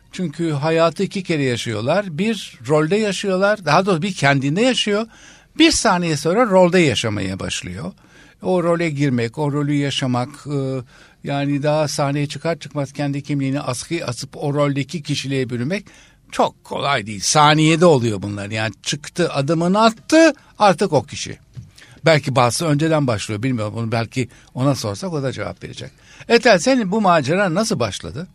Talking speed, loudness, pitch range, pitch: 150 wpm, -18 LUFS, 130-175 Hz, 145 Hz